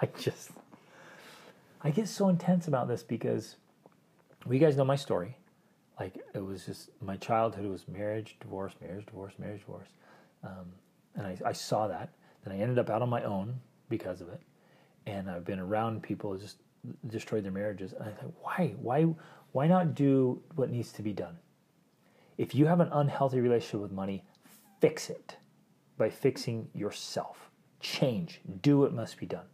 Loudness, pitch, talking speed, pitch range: -32 LUFS, 115 Hz, 180 wpm, 100-145 Hz